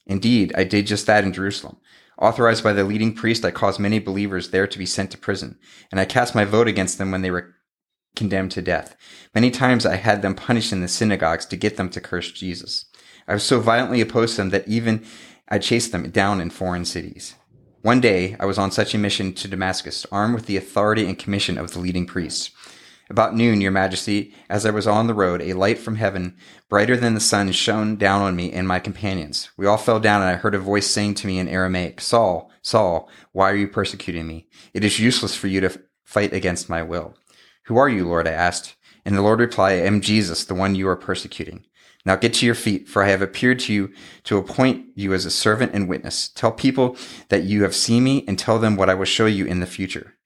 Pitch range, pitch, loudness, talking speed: 95-110 Hz, 100 Hz, -20 LUFS, 235 wpm